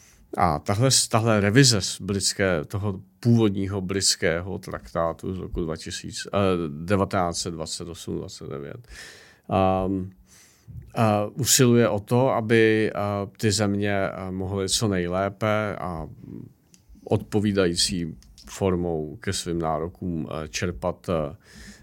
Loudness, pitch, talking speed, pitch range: -24 LUFS, 95 Hz, 90 wpm, 90-105 Hz